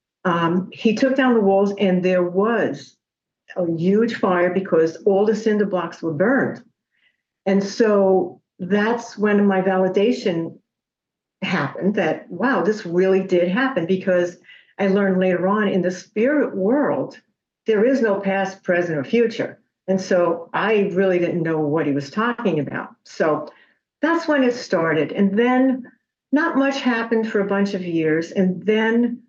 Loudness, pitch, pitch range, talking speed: -20 LUFS, 195 Hz, 180-225 Hz, 155 wpm